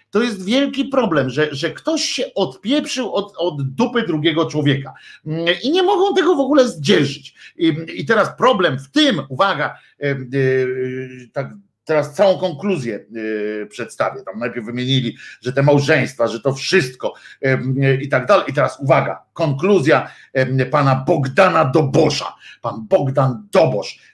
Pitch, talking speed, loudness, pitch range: 155 Hz, 150 wpm, -18 LUFS, 135-195 Hz